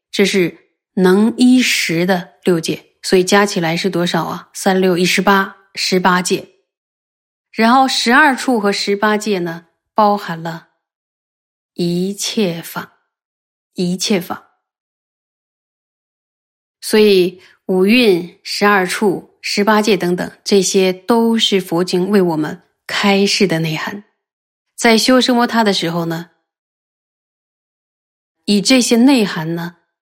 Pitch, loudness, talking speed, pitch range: 195 Hz, -14 LUFS, 170 characters per minute, 175-215 Hz